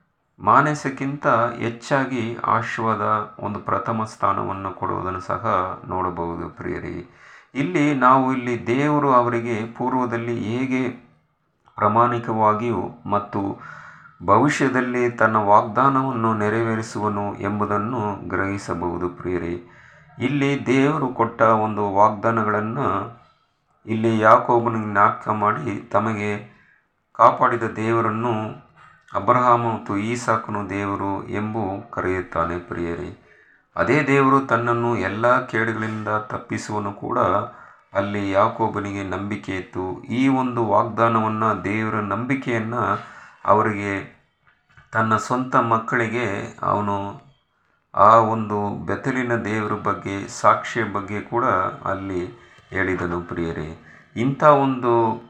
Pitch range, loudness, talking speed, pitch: 100-120 Hz, -21 LUFS, 85 wpm, 110 Hz